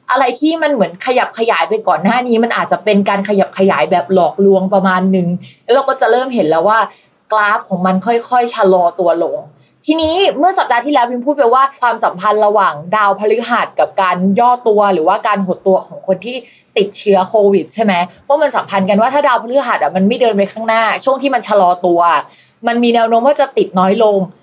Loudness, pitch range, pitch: -13 LUFS, 190-240 Hz, 215 Hz